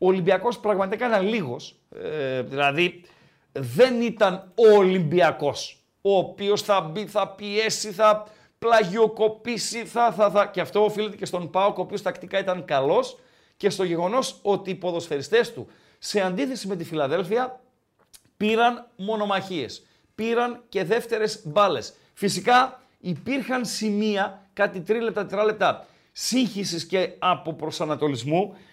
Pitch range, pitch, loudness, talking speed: 185-225 Hz, 205 Hz, -24 LUFS, 125 wpm